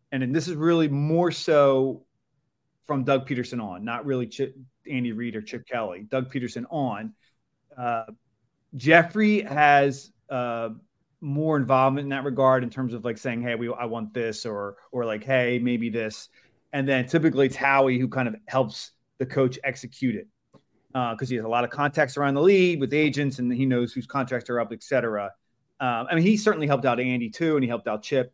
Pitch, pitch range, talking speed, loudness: 130 Hz, 120-140 Hz, 205 wpm, -25 LUFS